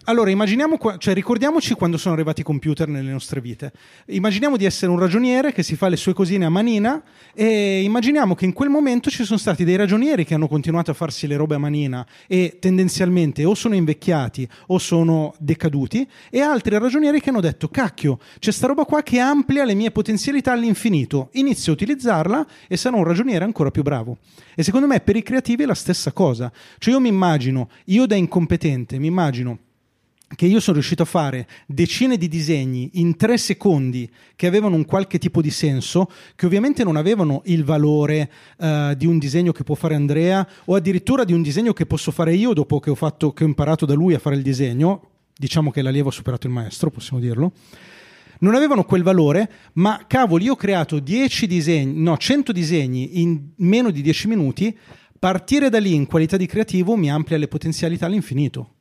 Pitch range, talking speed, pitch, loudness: 150-215 Hz, 195 wpm, 175 Hz, -19 LUFS